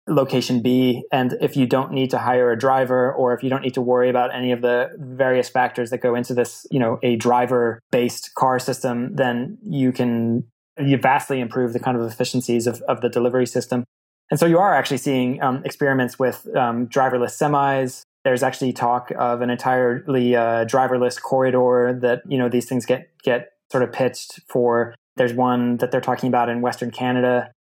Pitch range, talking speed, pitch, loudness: 120-130 Hz, 195 wpm, 125 Hz, -20 LUFS